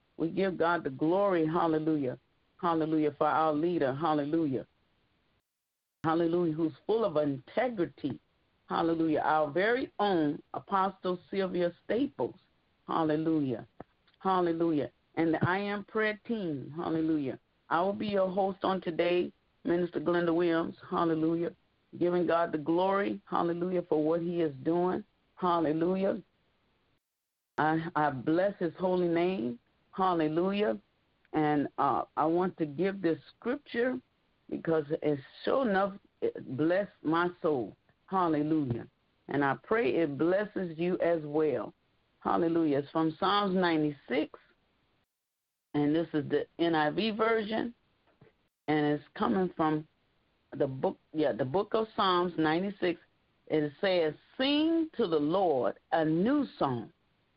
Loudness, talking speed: -31 LUFS, 125 wpm